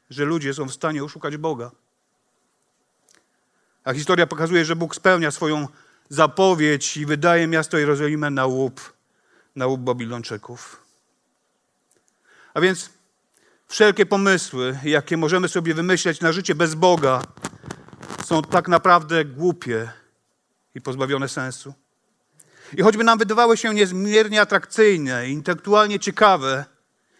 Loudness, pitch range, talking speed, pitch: -20 LUFS, 140-185 Hz, 115 wpm, 160 Hz